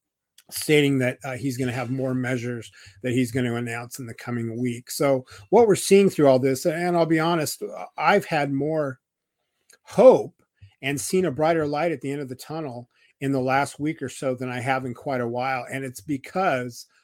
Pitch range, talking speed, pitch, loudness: 125-150 Hz, 210 wpm, 135 Hz, -23 LUFS